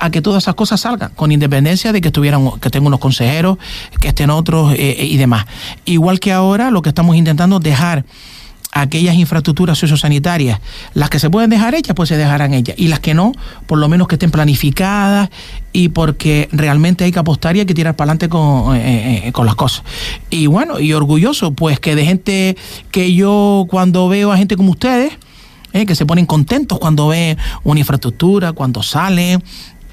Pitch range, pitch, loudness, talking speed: 145-185 Hz, 165 Hz, -12 LUFS, 195 wpm